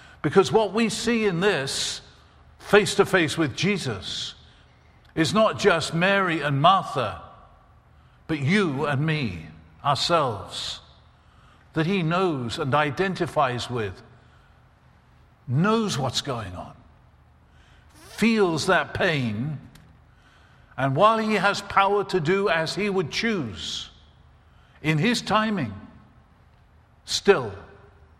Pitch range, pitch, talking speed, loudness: 125-200 Hz, 160 Hz, 105 wpm, -23 LUFS